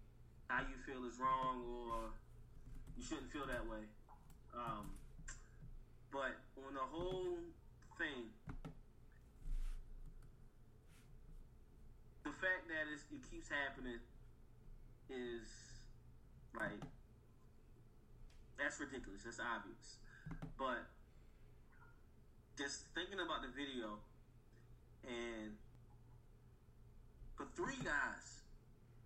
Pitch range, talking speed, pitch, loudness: 115-135 Hz, 85 wpm, 120 Hz, -47 LUFS